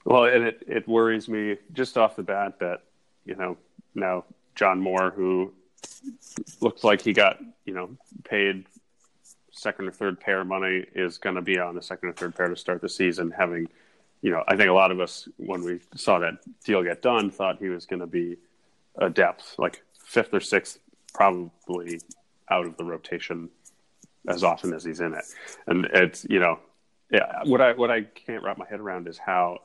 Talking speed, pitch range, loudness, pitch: 200 wpm, 90-105 Hz, -25 LUFS, 95 Hz